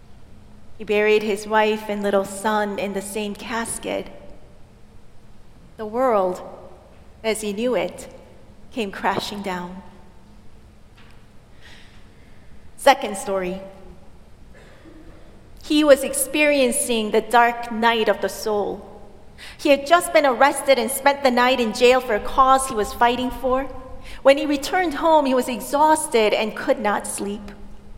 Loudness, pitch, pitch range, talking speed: -20 LUFS, 230 Hz, 205-265 Hz, 130 wpm